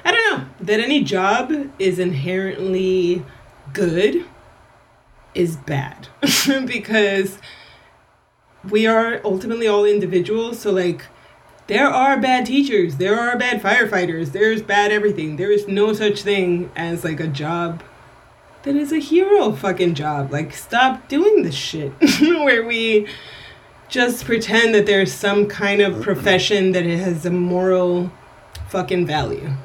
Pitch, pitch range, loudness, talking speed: 200 Hz, 180-230 Hz, -18 LUFS, 135 wpm